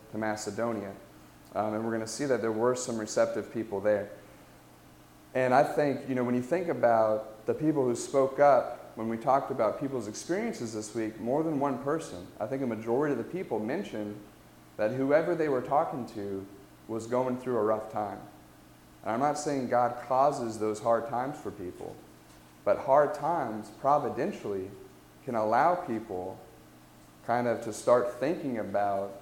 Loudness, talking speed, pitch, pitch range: -30 LUFS, 175 wpm, 115 Hz, 105-130 Hz